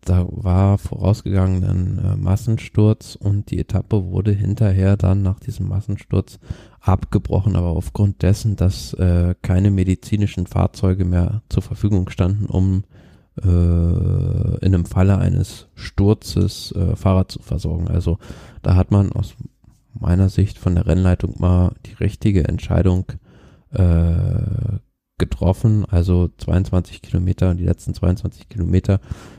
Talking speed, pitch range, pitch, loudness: 125 wpm, 90-105 Hz, 95 Hz, -19 LUFS